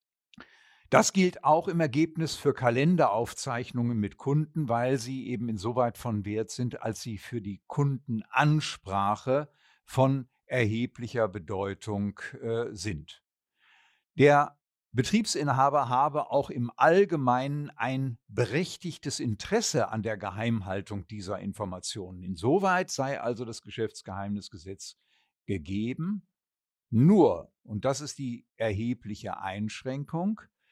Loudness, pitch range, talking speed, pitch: -29 LUFS, 105-145 Hz, 105 wpm, 120 Hz